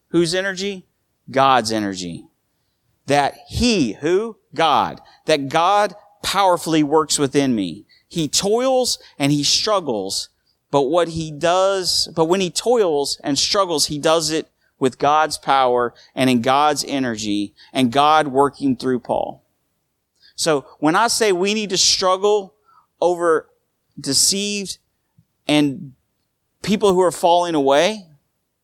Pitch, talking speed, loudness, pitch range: 155 Hz, 125 wpm, -18 LUFS, 135-190 Hz